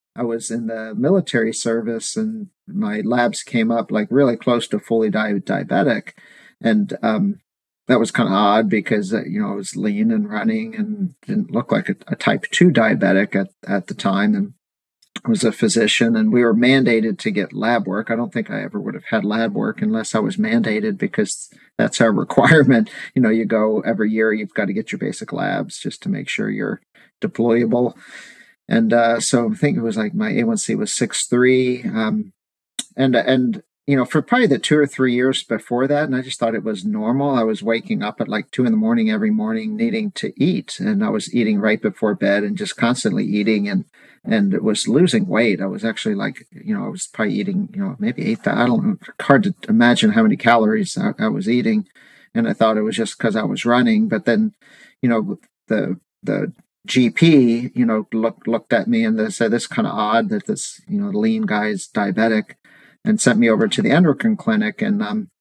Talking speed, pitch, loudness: 215 wpm, 195 Hz, -19 LUFS